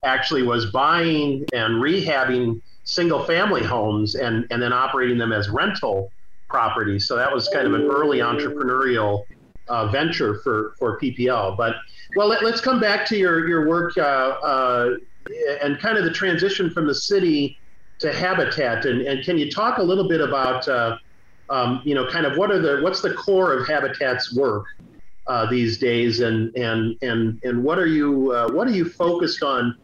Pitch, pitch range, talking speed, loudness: 130 Hz, 115-170 Hz, 180 wpm, -21 LUFS